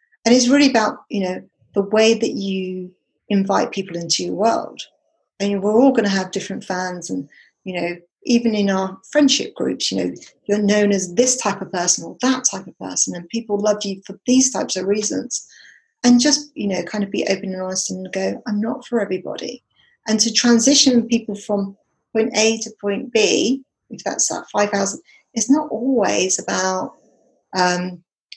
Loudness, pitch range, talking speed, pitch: -19 LUFS, 190-240 Hz, 190 wpm, 205 Hz